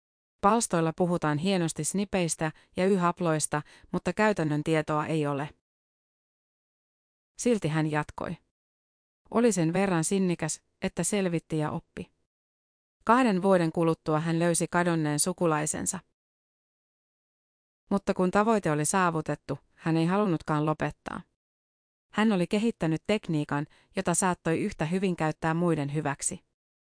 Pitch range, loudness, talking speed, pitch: 155-190 Hz, -28 LUFS, 110 wpm, 165 Hz